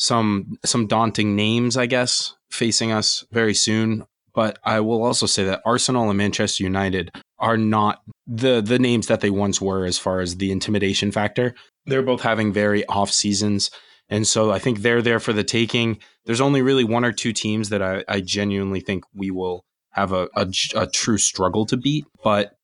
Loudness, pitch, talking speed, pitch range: -20 LUFS, 110 Hz, 195 wpm, 100-115 Hz